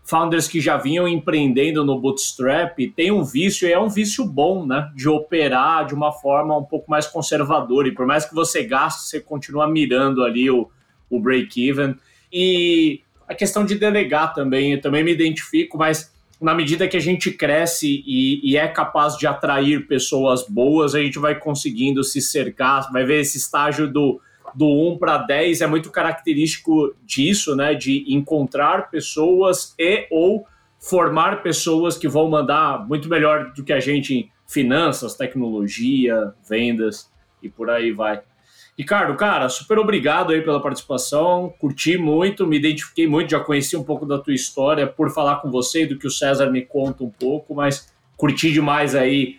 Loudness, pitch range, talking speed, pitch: -19 LUFS, 140-165 Hz, 175 wpm, 150 Hz